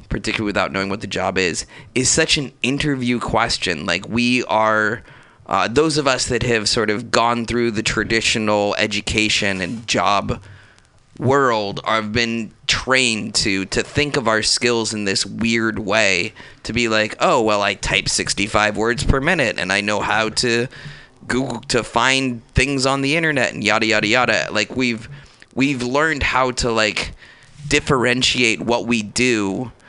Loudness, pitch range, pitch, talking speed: -18 LUFS, 110-130 Hz, 115 Hz, 165 wpm